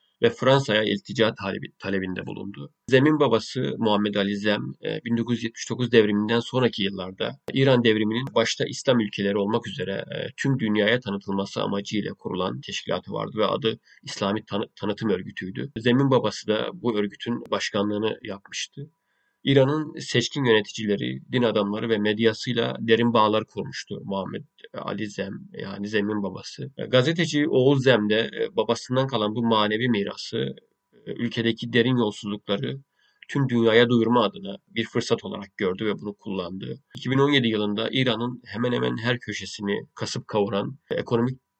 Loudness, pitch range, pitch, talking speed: -24 LUFS, 105-125 Hz, 115 Hz, 130 wpm